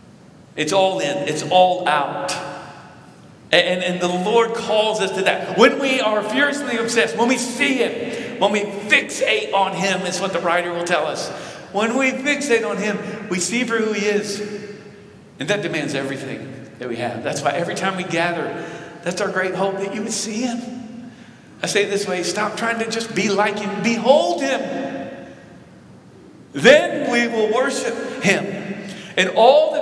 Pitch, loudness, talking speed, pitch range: 205 Hz, -19 LUFS, 180 wpm, 180-230 Hz